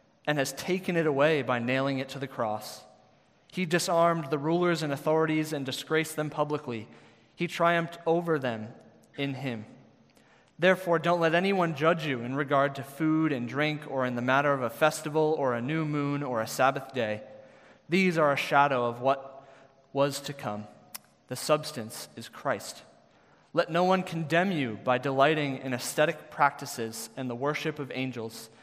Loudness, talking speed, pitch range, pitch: -28 LUFS, 170 wpm, 130-160 Hz, 140 Hz